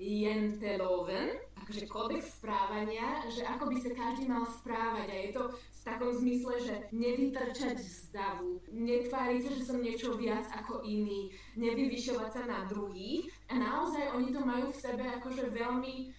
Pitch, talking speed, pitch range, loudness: 240 Hz, 150 wpm, 215-255 Hz, -36 LUFS